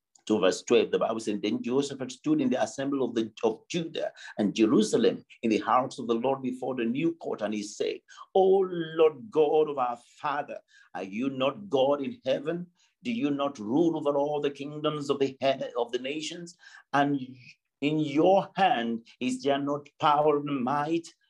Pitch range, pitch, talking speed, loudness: 130-165 Hz, 145 Hz, 190 wpm, -28 LUFS